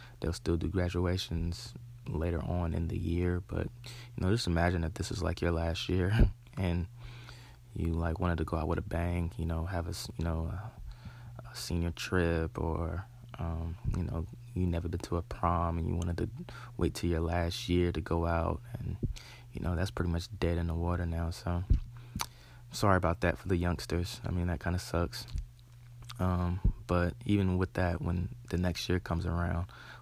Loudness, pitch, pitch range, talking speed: -34 LUFS, 90 Hz, 85-105 Hz, 195 wpm